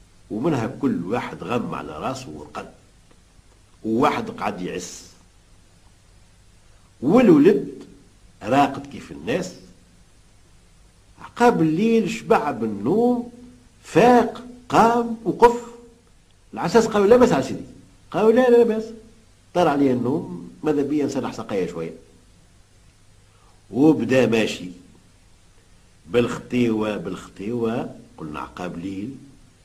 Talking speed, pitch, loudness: 95 wpm, 105 Hz, -20 LUFS